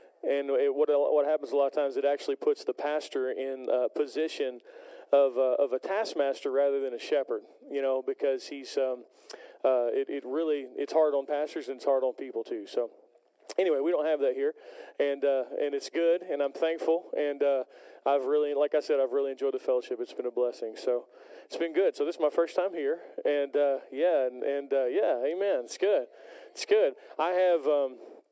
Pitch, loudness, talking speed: 160 Hz, -29 LUFS, 220 wpm